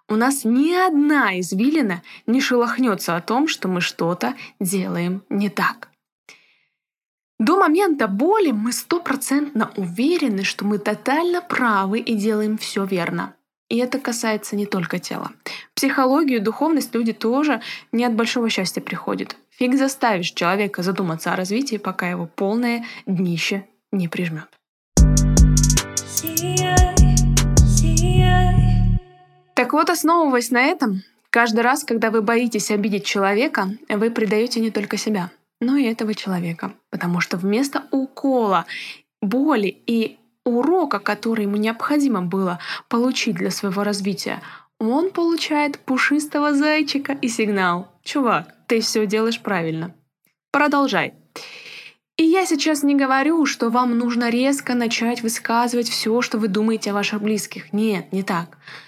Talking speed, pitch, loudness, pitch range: 130 wpm, 225 Hz, -20 LUFS, 195-265 Hz